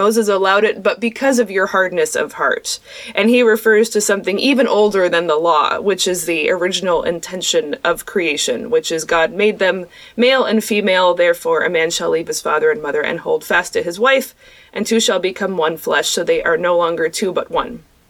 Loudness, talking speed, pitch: -16 LUFS, 210 wpm, 210 Hz